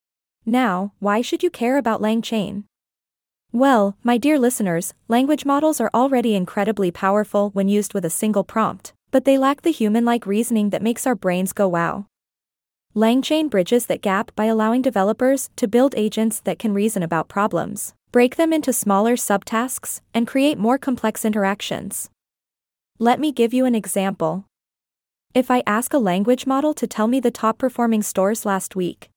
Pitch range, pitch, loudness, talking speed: 200-250 Hz, 225 Hz, -20 LUFS, 170 wpm